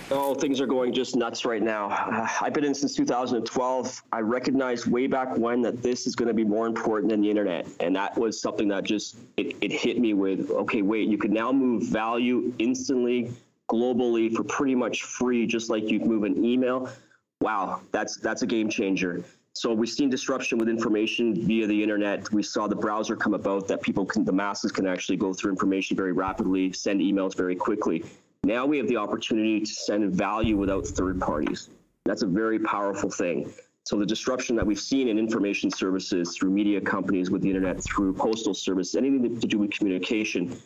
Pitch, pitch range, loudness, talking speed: 110 Hz, 100-125 Hz, -26 LUFS, 200 wpm